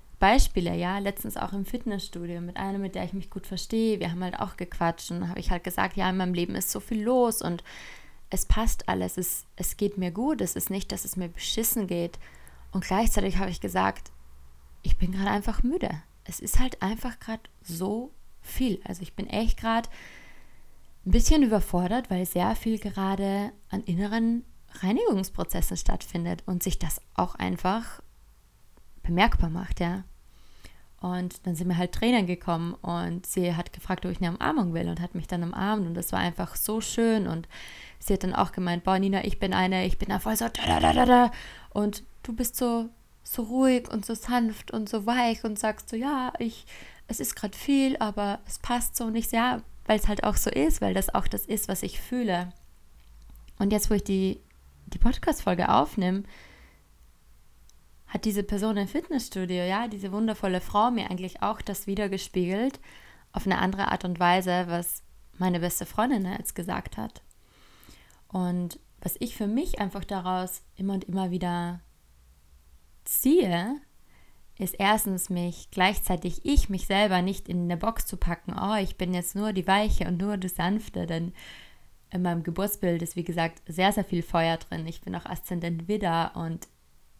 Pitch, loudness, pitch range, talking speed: 185 Hz, -28 LUFS, 175-215 Hz, 180 wpm